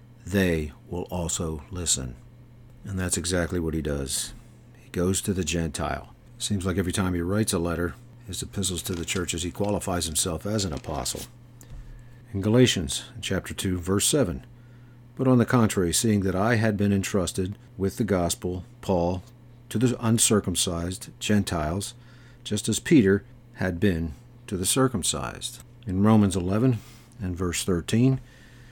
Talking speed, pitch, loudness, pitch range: 150 wpm, 100 Hz, -26 LUFS, 90-120 Hz